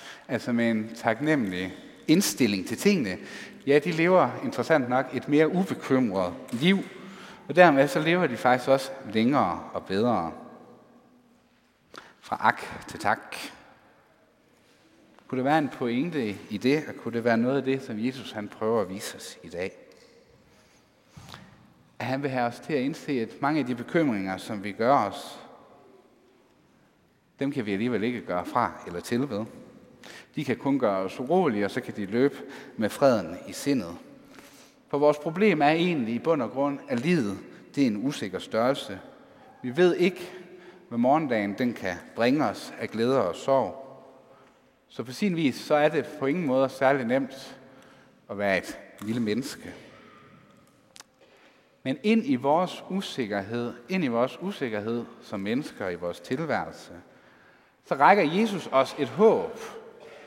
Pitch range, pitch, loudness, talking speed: 115-175 Hz, 135 Hz, -26 LUFS, 160 wpm